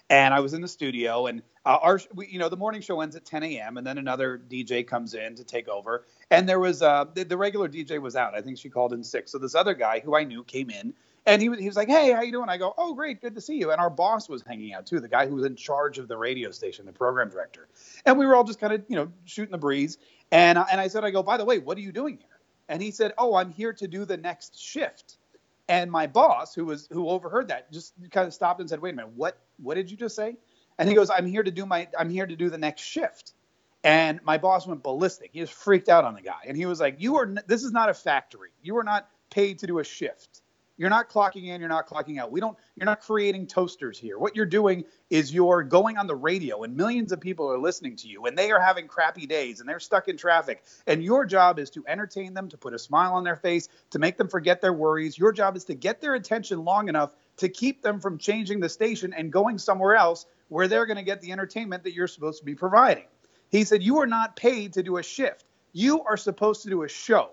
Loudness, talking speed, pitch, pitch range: -25 LUFS, 275 wpm, 185 Hz, 160-215 Hz